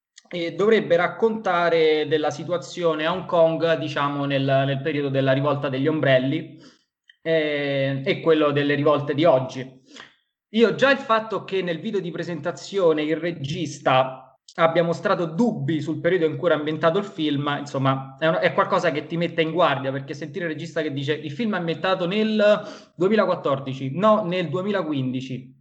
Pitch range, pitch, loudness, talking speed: 145-175 Hz, 160 Hz, -22 LUFS, 165 wpm